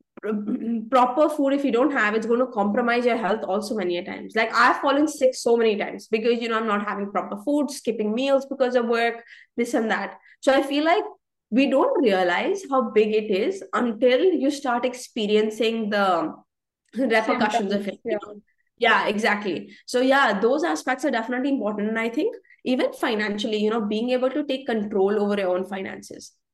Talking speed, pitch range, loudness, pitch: 190 wpm, 215-265 Hz, -23 LUFS, 235 Hz